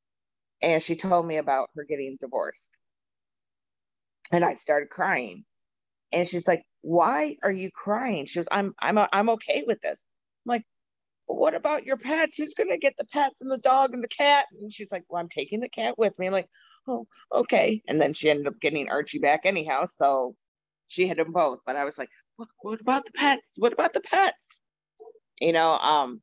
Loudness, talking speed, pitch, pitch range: -26 LUFS, 205 wpm, 190 Hz, 155-255 Hz